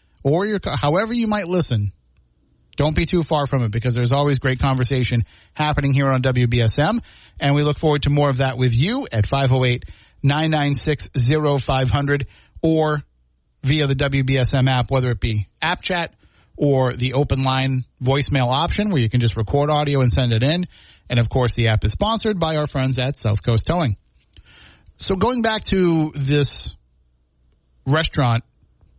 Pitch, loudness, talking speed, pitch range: 135 Hz, -19 LUFS, 165 wpm, 115-150 Hz